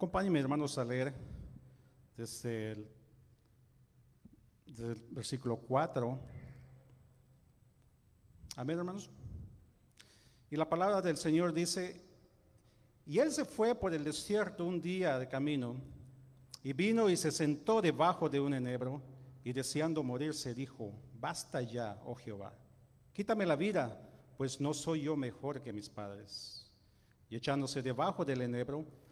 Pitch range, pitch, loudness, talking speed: 120-155 Hz, 130 Hz, -37 LUFS, 130 wpm